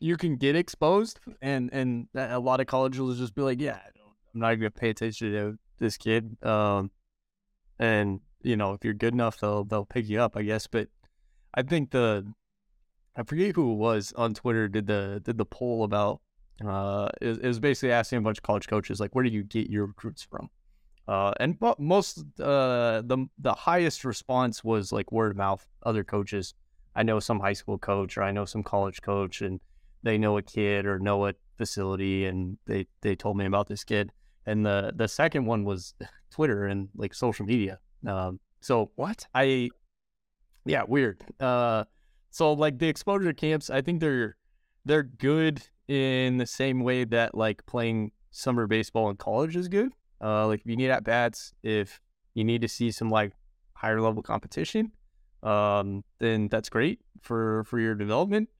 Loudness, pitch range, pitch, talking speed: -28 LUFS, 100-125 Hz, 110 Hz, 190 wpm